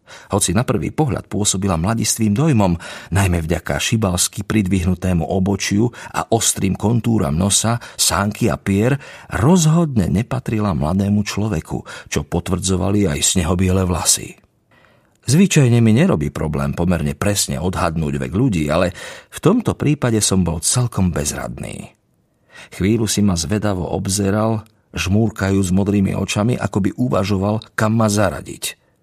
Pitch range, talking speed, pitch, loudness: 90-110 Hz, 120 wpm, 100 Hz, -18 LUFS